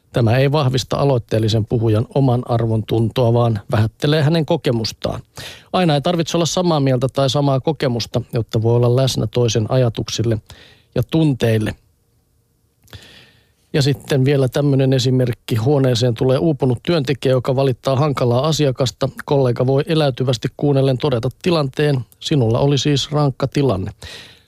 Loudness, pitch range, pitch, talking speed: -17 LUFS, 115-145 Hz, 130 Hz, 130 wpm